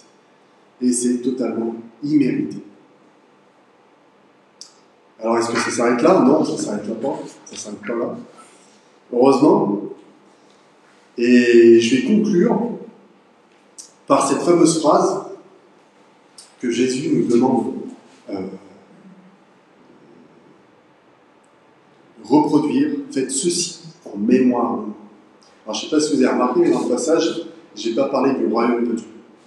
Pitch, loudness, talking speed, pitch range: 125 Hz, -18 LUFS, 120 wpm, 115-175 Hz